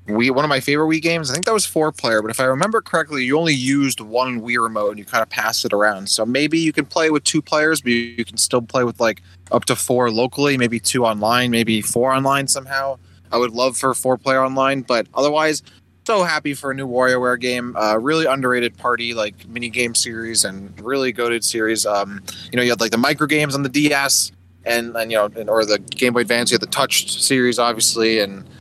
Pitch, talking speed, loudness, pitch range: 125 Hz, 240 wpm, -18 LUFS, 115-140 Hz